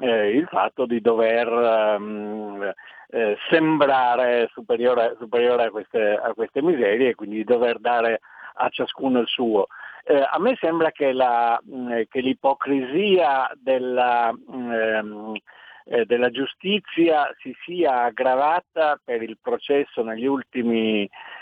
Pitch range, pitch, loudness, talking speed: 115-135 Hz, 120 Hz, -22 LUFS, 125 wpm